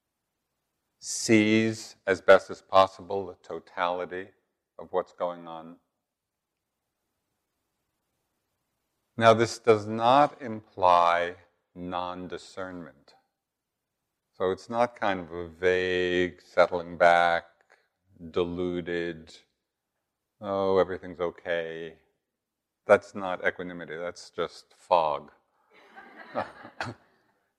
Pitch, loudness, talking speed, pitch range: 90 Hz, -26 LUFS, 80 wpm, 85-100 Hz